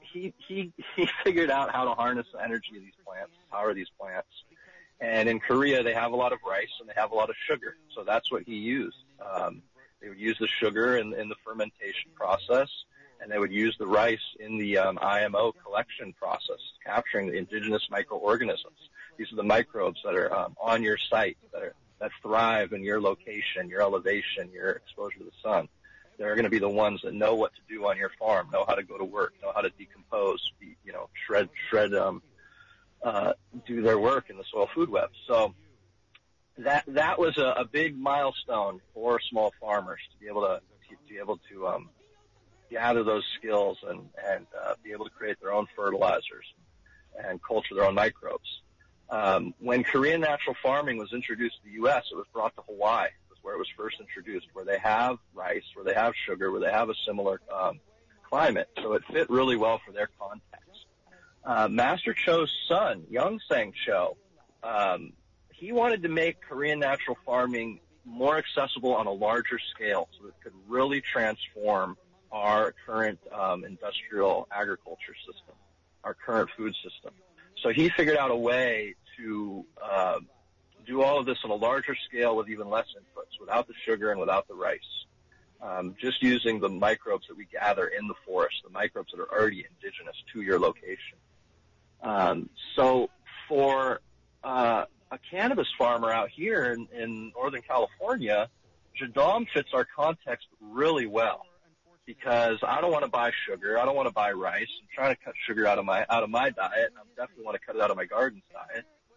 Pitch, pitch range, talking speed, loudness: 120 Hz, 110-175 Hz, 190 wpm, -28 LUFS